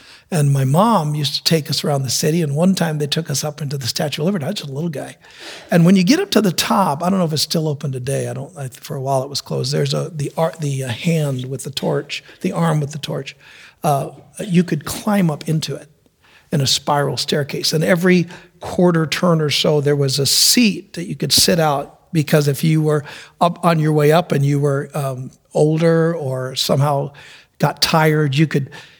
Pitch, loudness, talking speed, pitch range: 150 Hz, -17 LUFS, 235 wpm, 140-170 Hz